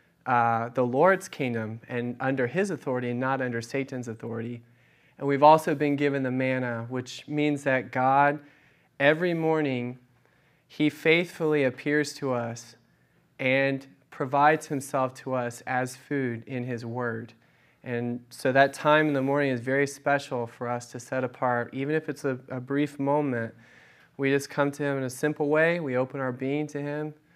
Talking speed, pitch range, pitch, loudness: 170 wpm, 125-145 Hz, 135 Hz, -27 LUFS